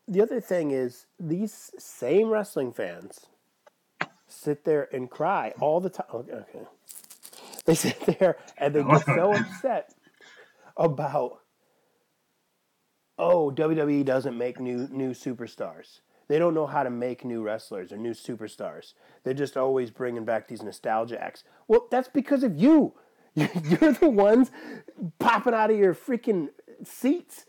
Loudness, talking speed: -26 LUFS, 145 wpm